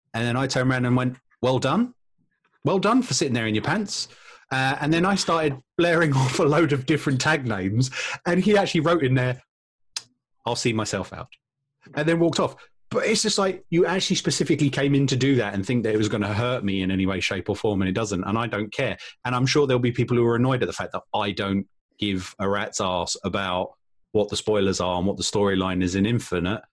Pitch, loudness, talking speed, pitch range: 125 Hz, -23 LUFS, 245 wpm, 105-155 Hz